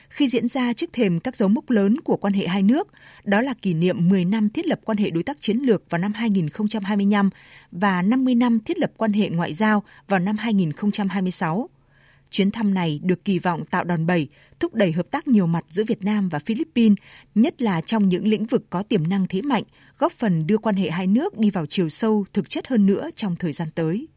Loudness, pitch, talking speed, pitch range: -22 LUFS, 205 Hz, 230 wpm, 185-225 Hz